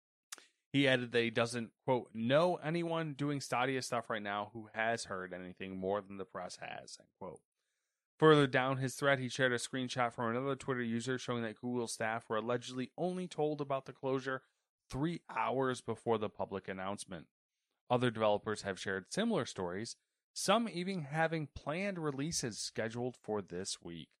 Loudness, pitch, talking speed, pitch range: -36 LUFS, 125 Hz, 170 wpm, 105-140 Hz